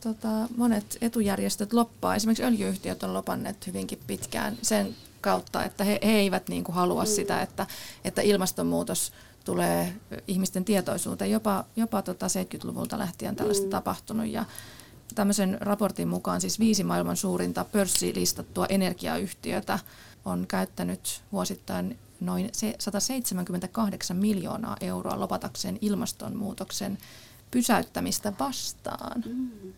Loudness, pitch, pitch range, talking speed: -29 LUFS, 200 Hz, 180-220 Hz, 105 wpm